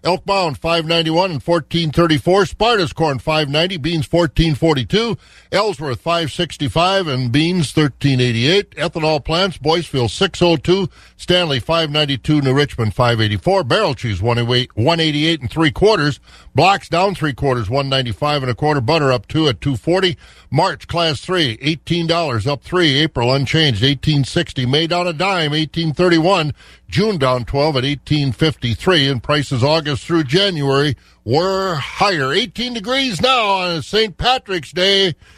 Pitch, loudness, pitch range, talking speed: 160 Hz, -16 LUFS, 140-175 Hz, 155 wpm